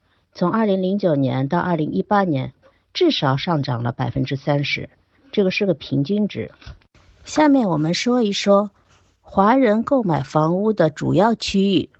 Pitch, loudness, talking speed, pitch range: 180 Hz, -19 LUFS, 235 characters per minute, 145-205 Hz